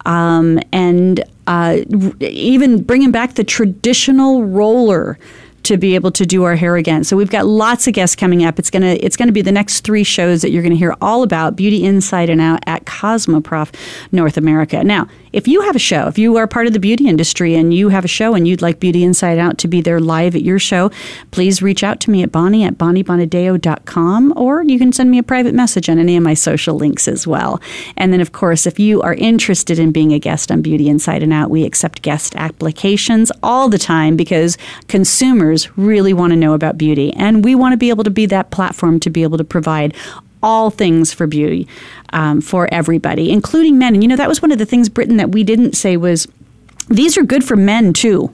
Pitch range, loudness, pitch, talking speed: 165-220 Hz, -12 LUFS, 185 Hz, 225 wpm